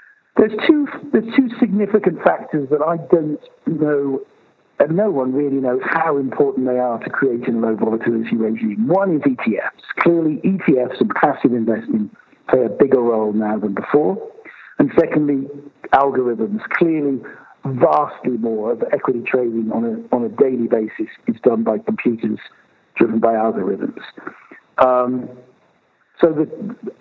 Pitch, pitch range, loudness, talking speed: 140 Hz, 115-185 Hz, -18 LUFS, 145 wpm